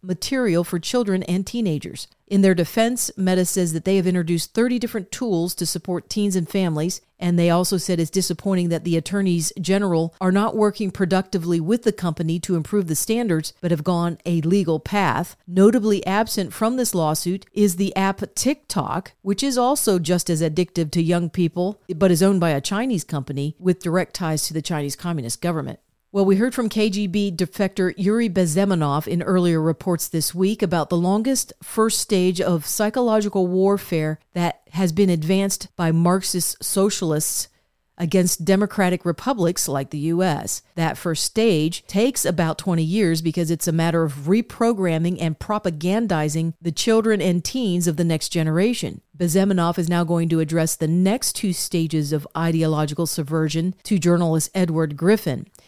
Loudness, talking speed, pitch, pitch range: -21 LUFS, 170 wpm, 180 Hz, 165-200 Hz